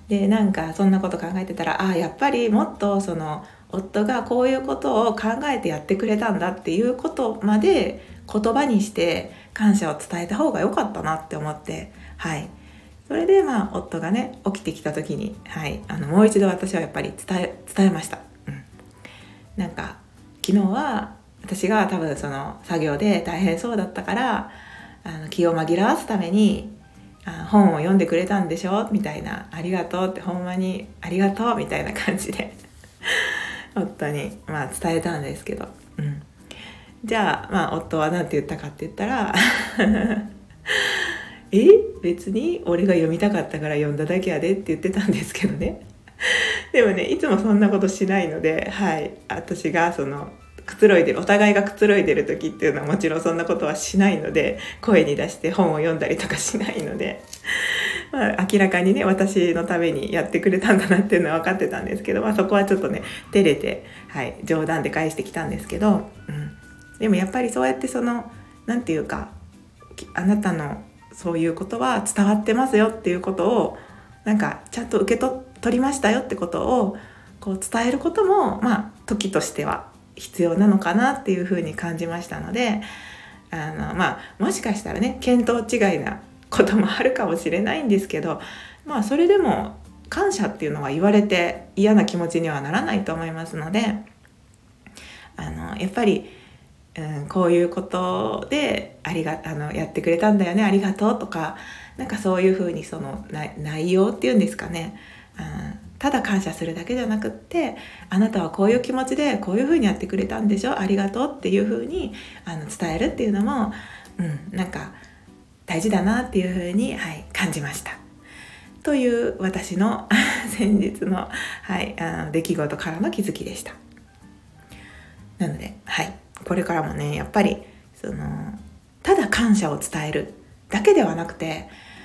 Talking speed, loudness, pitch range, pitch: 345 characters per minute, -22 LUFS, 170-215 Hz, 195 Hz